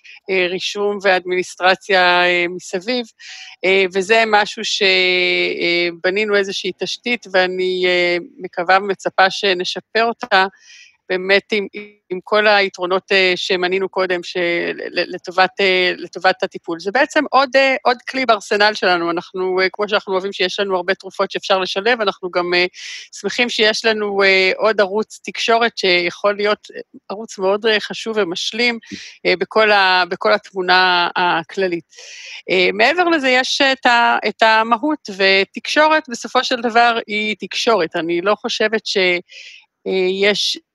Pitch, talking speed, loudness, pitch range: 195 Hz, 125 wpm, -16 LUFS, 185-225 Hz